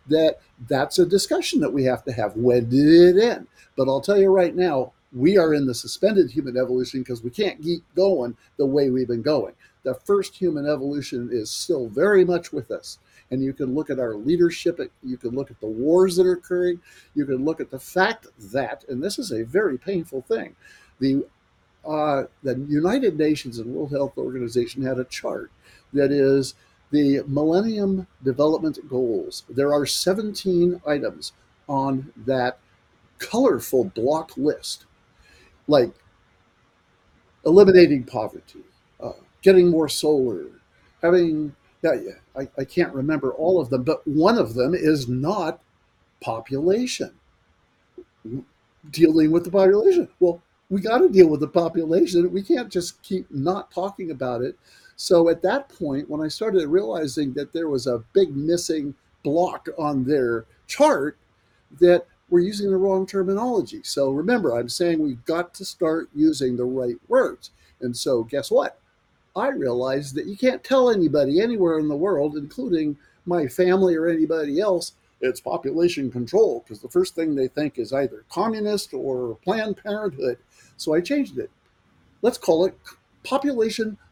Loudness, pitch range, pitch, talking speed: -22 LUFS, 135-190 Hz, 160 Hz, 160 wpm